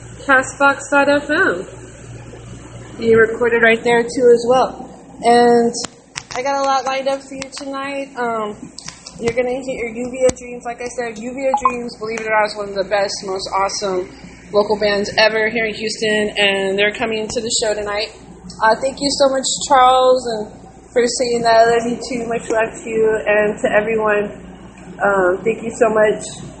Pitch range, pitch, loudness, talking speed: 215-255 Hz, 230 Hz, -17 LUFS, 180 wpm